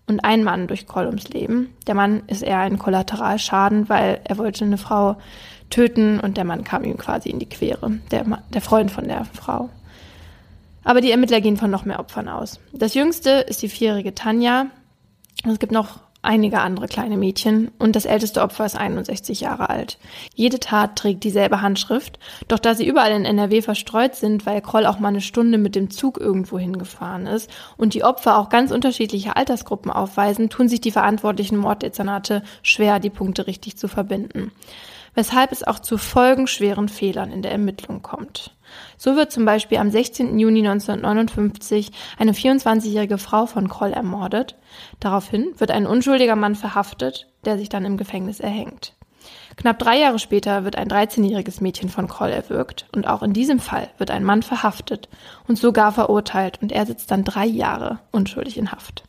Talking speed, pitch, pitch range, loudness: 180 wpm, 210 Hz, 200-225 Hz, -20 LUFS